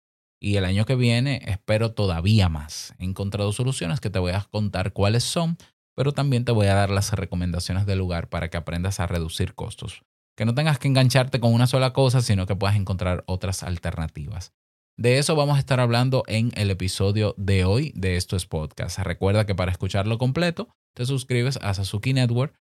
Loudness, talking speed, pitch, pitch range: -23 LUFS, 195 wpm, 100 Hz, 95-125 Hz